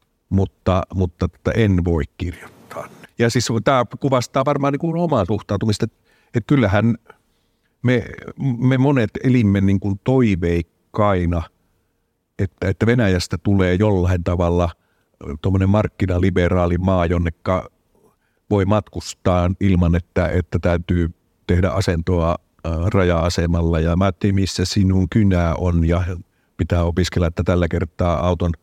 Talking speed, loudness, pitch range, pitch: 115 wpm, -19 LUFS, 85-105 Hz, 95 Hz